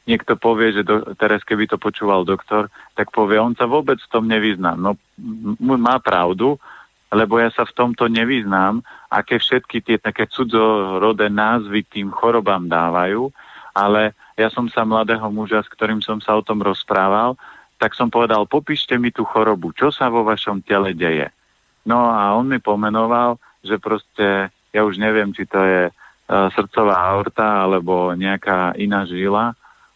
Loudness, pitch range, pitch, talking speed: -18 LUFS, 100-115 Hz, 110 Hz, 165 wpm